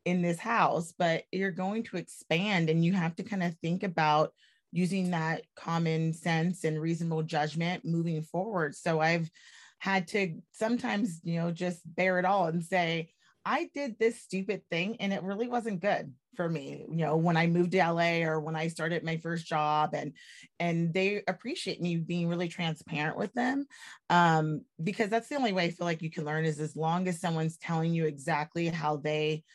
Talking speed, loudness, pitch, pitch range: 195 wpm, -31 LUFS, 170 Hz, 160-190 Hz